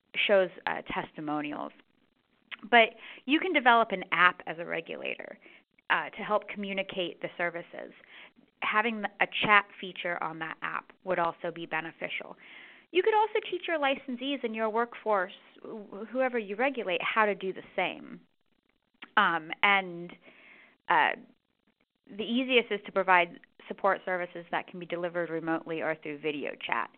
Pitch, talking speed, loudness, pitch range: 205 Hz, 145 wpm, -29 LUFS, 175-240 Hz